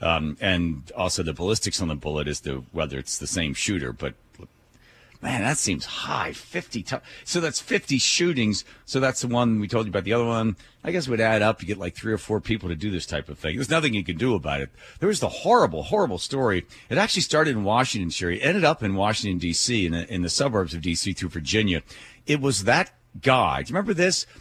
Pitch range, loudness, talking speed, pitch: 85-125 Hz, -24 LUFS, 235 wpm, 105 Hz